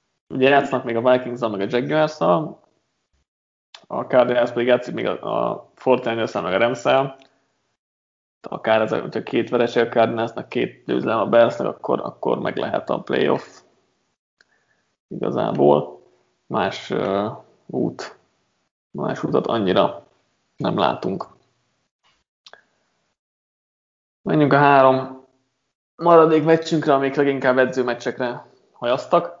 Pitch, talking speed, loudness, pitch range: 125 Hz, 110 wpm, -20 LUFS, 115-135 Hz